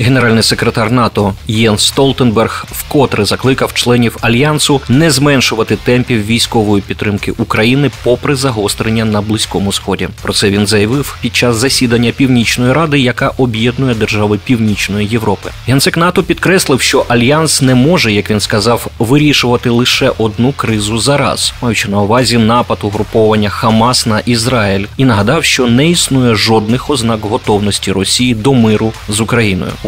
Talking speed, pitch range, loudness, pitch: 145 wpm, 105-130 Hz, -10 LUFS, 115 Hz